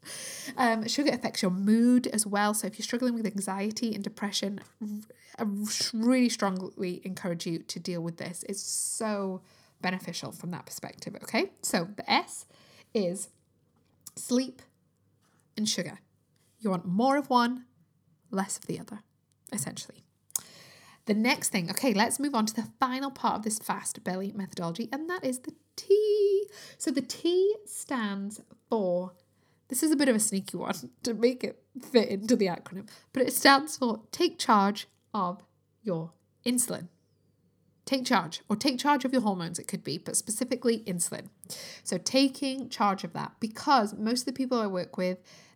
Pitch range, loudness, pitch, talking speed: 190-255 Hz, -29 LUFS, 220 Hz, 165 wpm